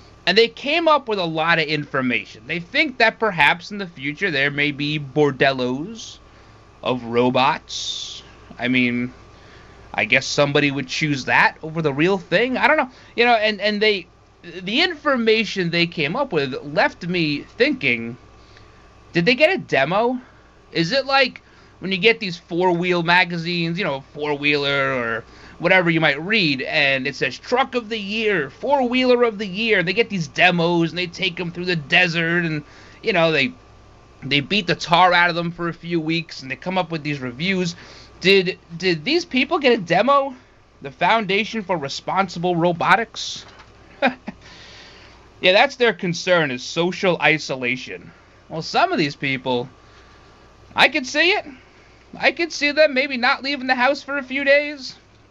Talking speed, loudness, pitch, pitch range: 170 wpm, -19 LUFS, 175 Hz, 145-220 Hz